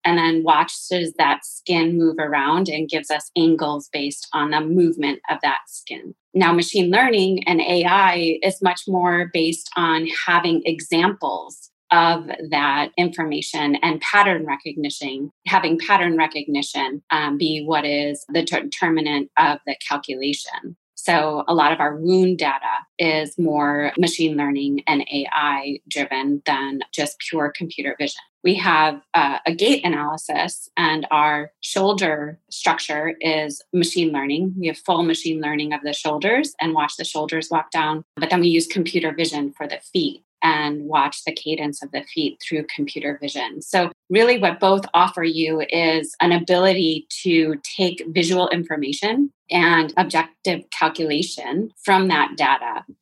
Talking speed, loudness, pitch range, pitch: 150 wpm, -20 LUFS, 150-180 Hz, 160 Hz